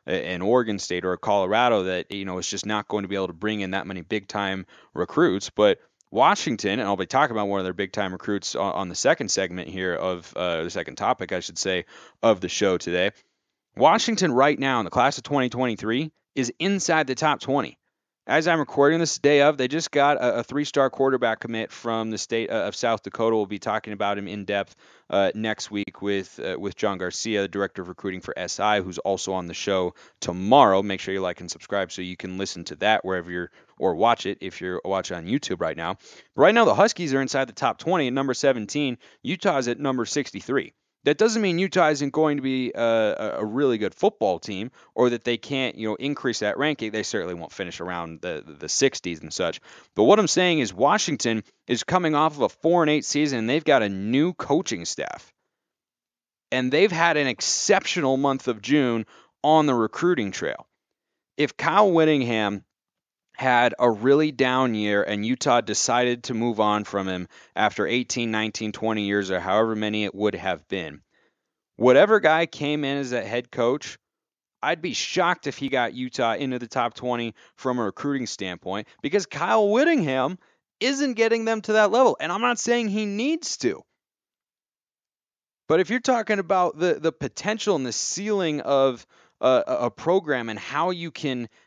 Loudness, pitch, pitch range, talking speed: -23 LUFS, 125 Hz, 100-150 Hz, 205 wpm